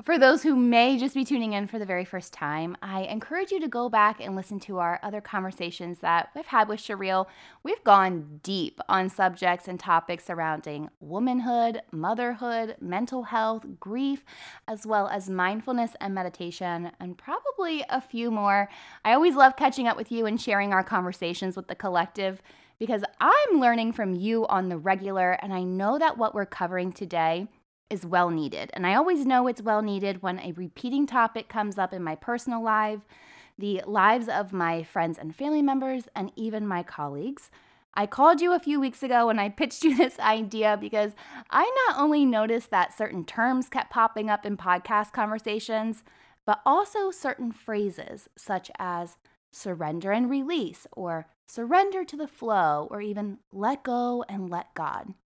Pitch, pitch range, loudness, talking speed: 215 Hz, 185-250 Hz, -26 LUFS, 180 wpm